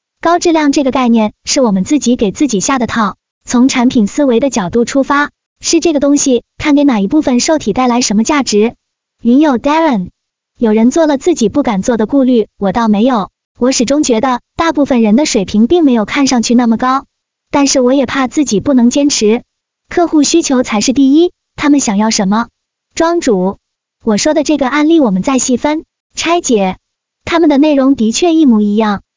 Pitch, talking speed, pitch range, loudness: 260 Hz, 295 characters per minute, 225-290 Hz, -11 LUFS